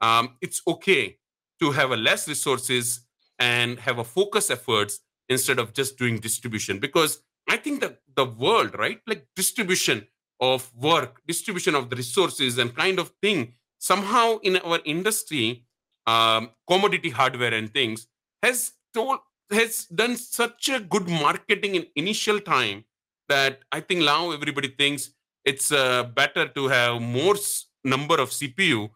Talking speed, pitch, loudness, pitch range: 150 wpm, 145 Hz, -23 LUFS, 125-195 Hz